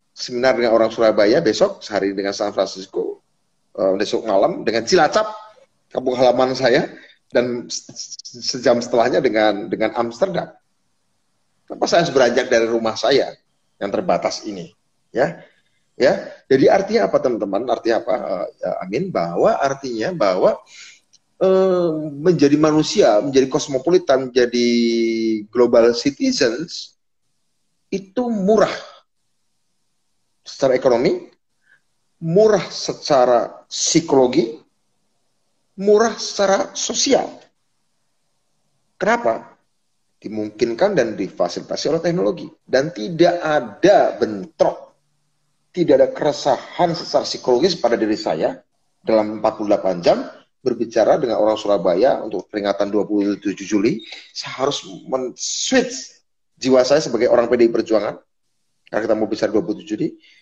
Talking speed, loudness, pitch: 110 wpm, -18 LUFS, 130 Hz